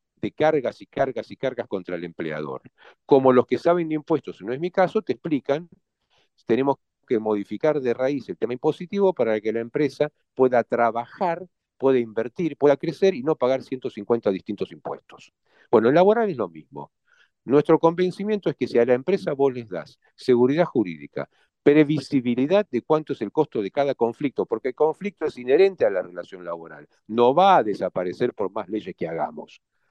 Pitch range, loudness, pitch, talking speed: 120-165 Hz, -23 LUFS, 140 Hz, 185 wpm